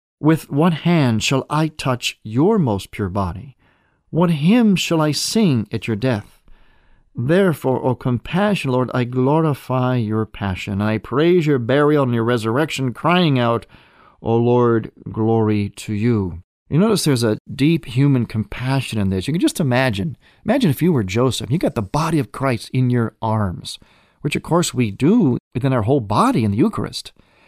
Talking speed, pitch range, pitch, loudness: 170 wpm, 110-155 Hz, 130 Hz, -18 LUFS